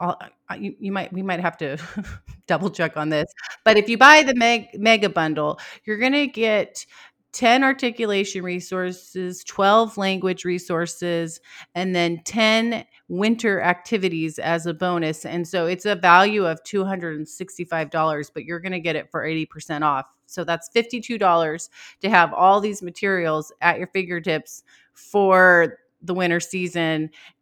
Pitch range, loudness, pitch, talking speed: 165-205 Hz, -20 LUFS, 180 Hz, 155 wpm